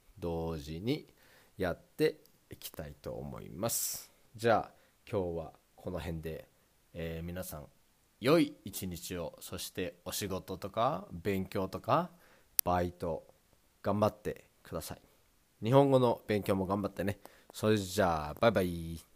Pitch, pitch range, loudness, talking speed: 95 Hz, 85-105 Hz, -34 LUFS, 250 characters per minute